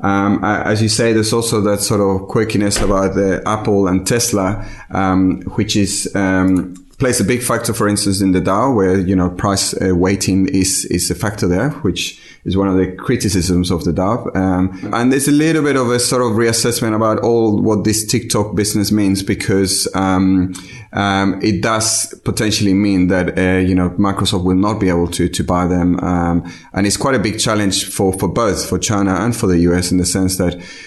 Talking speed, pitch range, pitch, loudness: 210 wpm, 95-110 Hz, 100 Hz, -15 LUFS